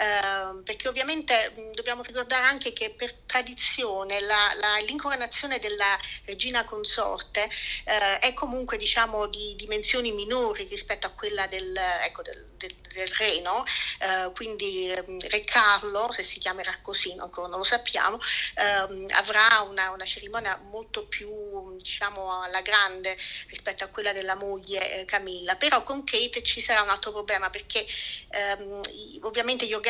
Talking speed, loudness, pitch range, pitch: 145 wpm, -26 LUFS, 190-235 Hz, 210 Hz